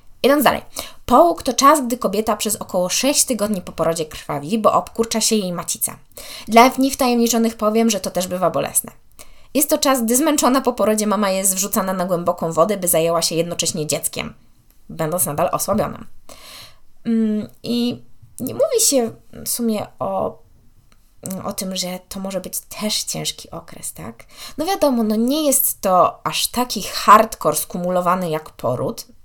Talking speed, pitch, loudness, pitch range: 160 wpm, 210 Hz, -18 LUFS, 180-240 Hz